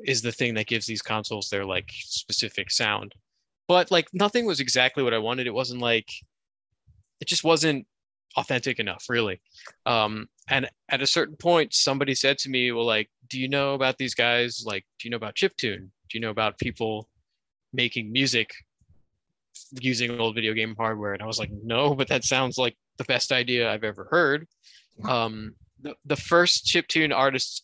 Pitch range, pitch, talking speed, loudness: 110-135 Hz, 120 Hz, 185 wpm, -25 LUFS